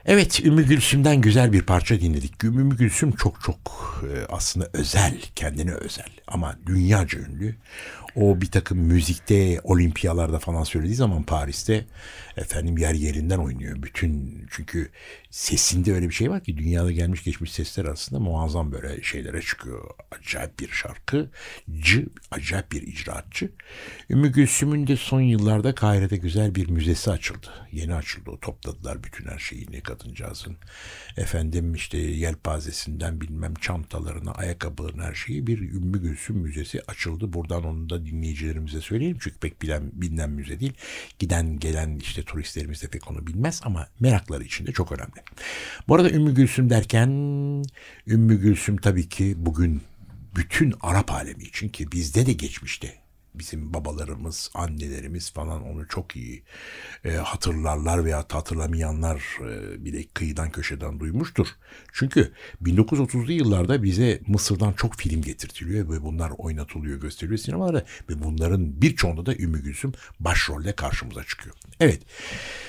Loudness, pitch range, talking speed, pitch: -24 LUFS, 80-105 Hz, 140 wpm, 85 Hz